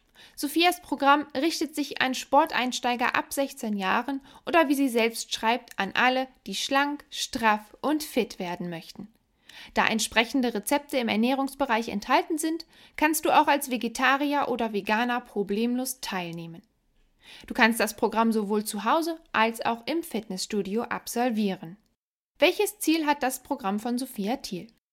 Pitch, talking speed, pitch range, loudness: 245 Hz, 140 wpm, 220-285 Hz, -26 LUFS